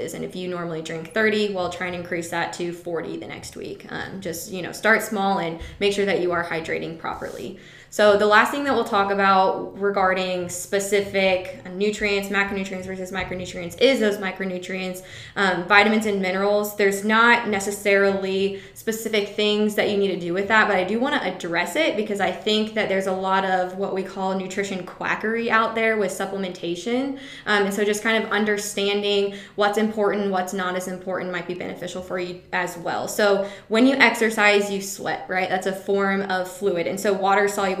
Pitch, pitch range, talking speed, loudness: 195 Hz, 185-210 Hz, 195 wpm, -22 LUFS